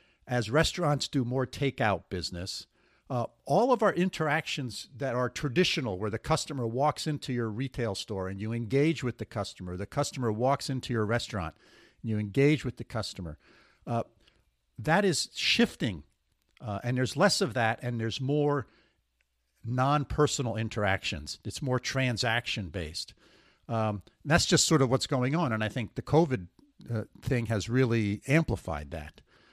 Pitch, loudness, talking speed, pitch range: 120 Hz, -29 LUFS, 160 wpm, 105-140 Hz